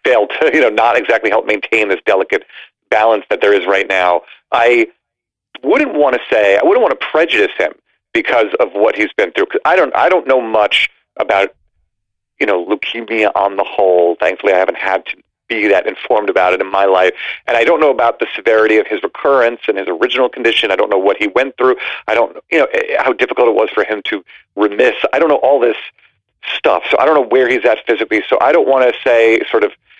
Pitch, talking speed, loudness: 125 Hz, 230 wpm, -13 LUFS